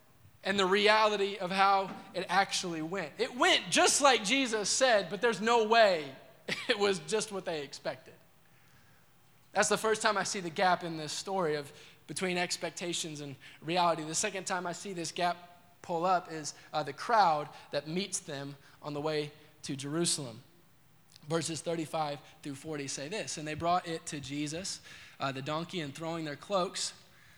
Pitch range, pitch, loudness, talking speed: 150-195 Hz, 170 Hz, -31 LUFS, 175 wpm